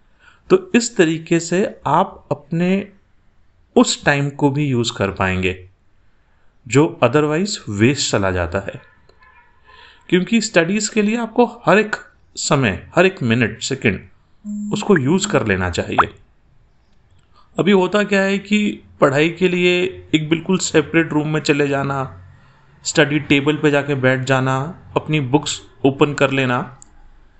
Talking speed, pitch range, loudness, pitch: 135 wpm, 120-185 Hz, -17 LUFS, 150 Hz